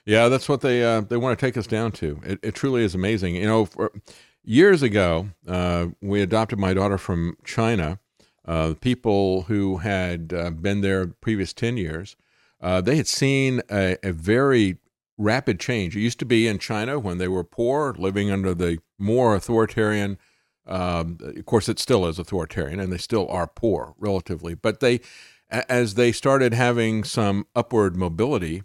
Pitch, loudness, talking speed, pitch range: 100 Hz, -23 LUFS, 180 wpm, 90-115 Hz